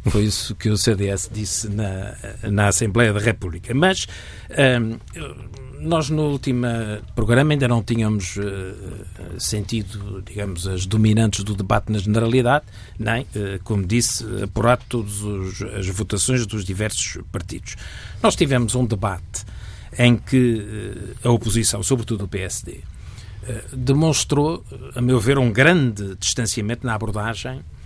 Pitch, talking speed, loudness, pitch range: 110 Hz, 135 wpm, -21 LUFS, 100-120 Hz